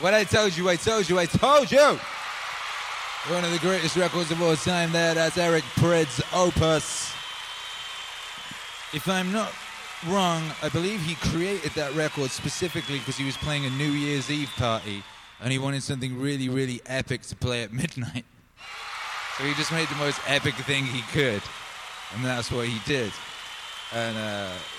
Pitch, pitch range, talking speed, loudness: 145 Hz, 130-170 Hz, 170 wpm, -26 LUFS